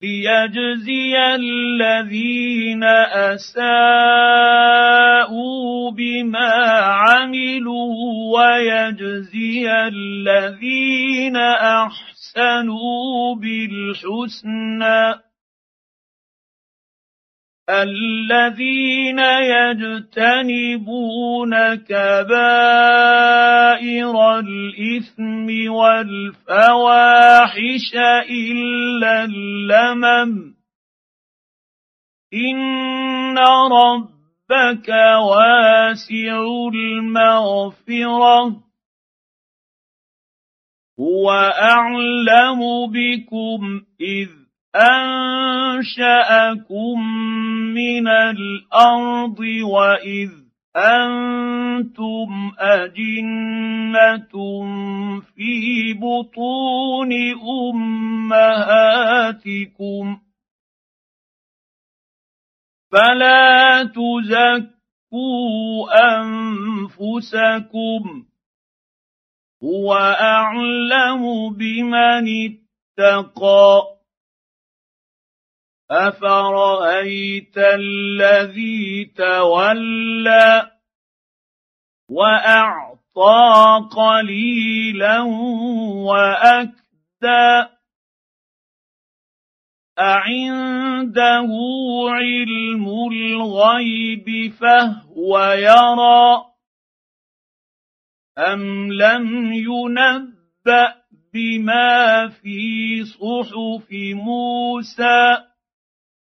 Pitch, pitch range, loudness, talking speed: 225 Hz, 220-240 Hz, -15 LUFS, 35 wpm